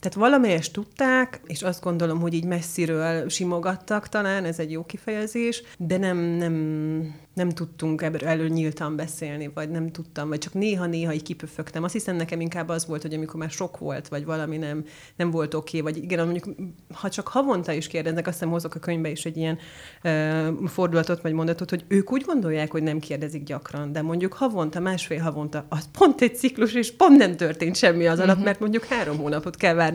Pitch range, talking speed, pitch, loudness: 160-185 Hz, 195 wpm, 165 Hz, -25 LUFS